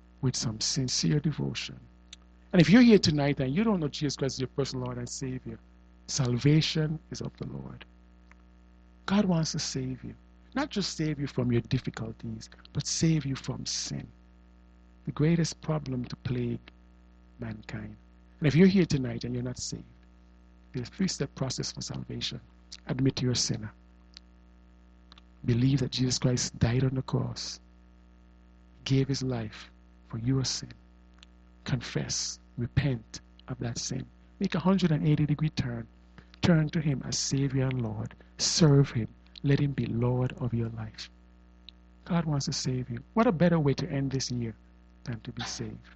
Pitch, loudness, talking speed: 120 Hz, -29 LUFS, 160 wpm